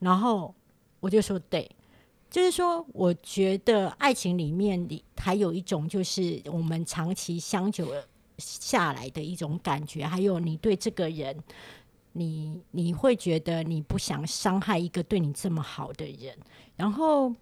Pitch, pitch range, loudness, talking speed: 180 Hz, 165-205 Hz, -28 LUFS, 225 characters per minute